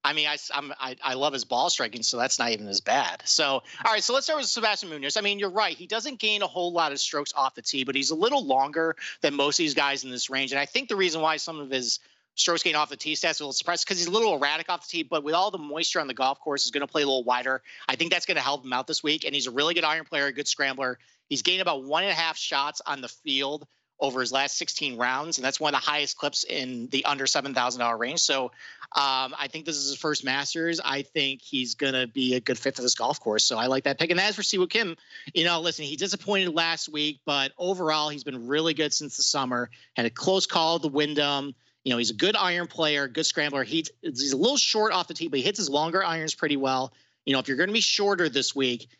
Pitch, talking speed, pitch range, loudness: 150 Hz, 285 wpm, 135-170 Hz, -25 LUFS